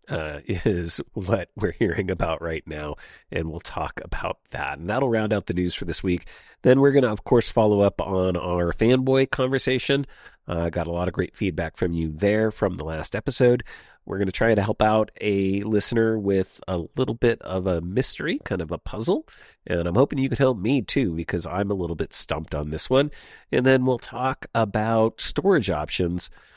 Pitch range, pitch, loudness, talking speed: 85-125 Hz, 100 Hz, -24 LUFS, 210 wpm